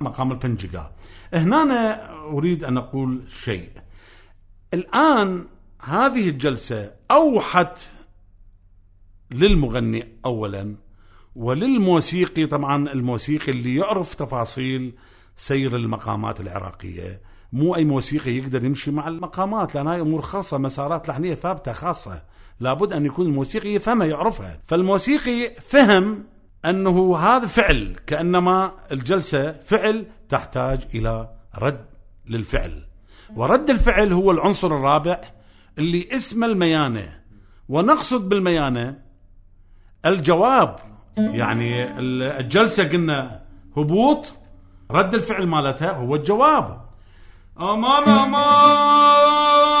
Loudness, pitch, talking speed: -20 LUFS, 140 Hz, 95 wpm